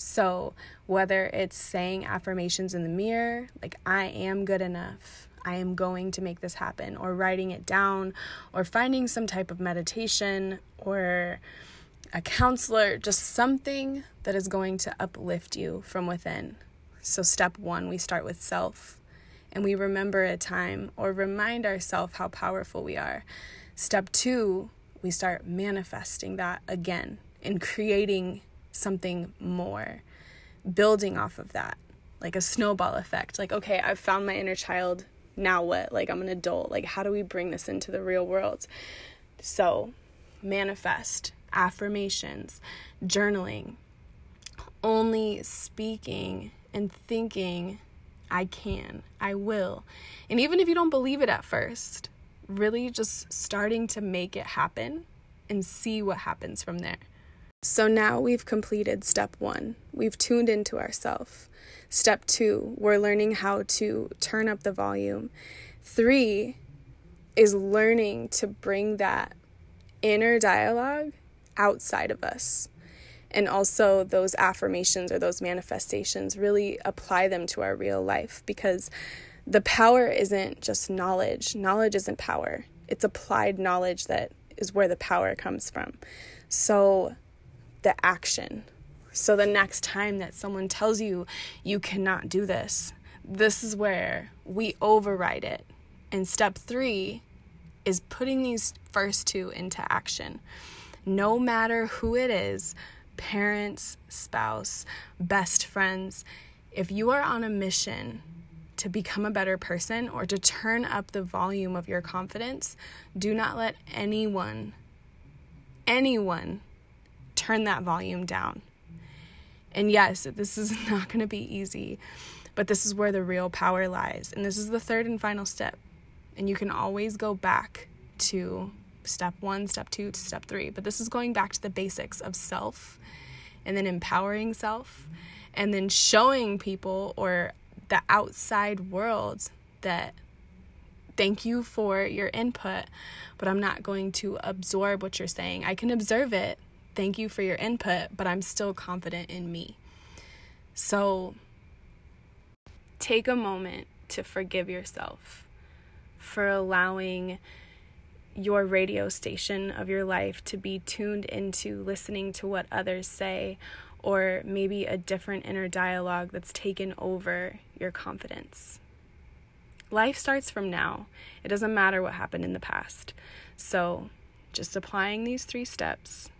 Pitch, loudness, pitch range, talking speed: 195 Hz, -27 LUFS, 180-210 Hz, 140 wpm